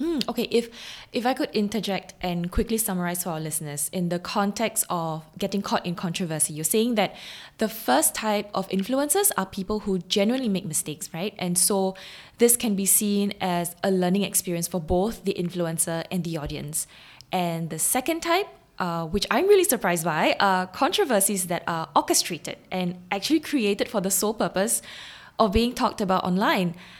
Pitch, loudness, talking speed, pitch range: 195 Hz, -24 LUFS, 175 wpm, 175-220 Hz